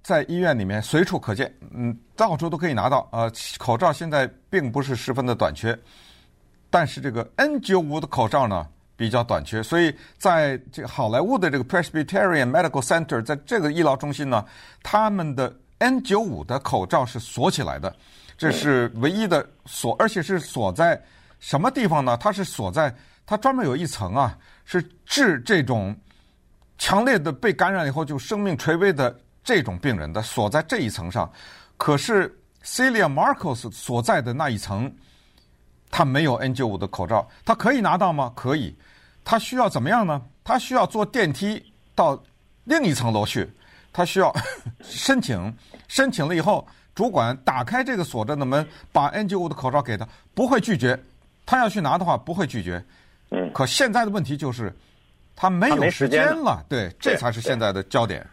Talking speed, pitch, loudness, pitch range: 280 characters per minute, 140 Hz, -23 LUFS, 115-180 Hz